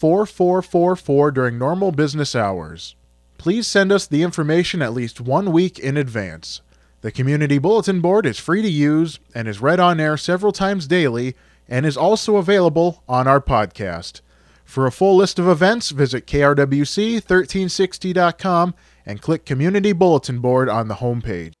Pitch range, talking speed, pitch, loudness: 125-185 Hz, 155 wpm, 150 Hz, -18 LUFS